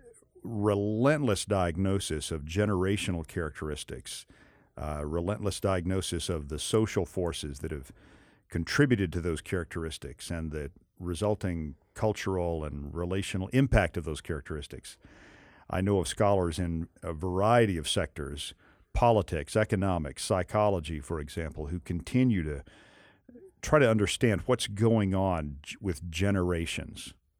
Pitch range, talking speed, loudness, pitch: 80-105 Hz, 115 wpm, -30 LUFS, 90 Hz